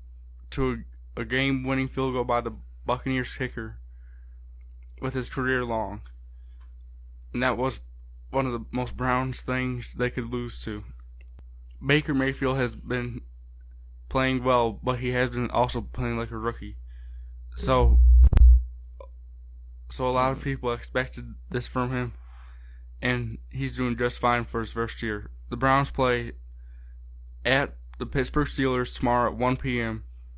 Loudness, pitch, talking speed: -26 LUFS, 115 Hz, 140 wpm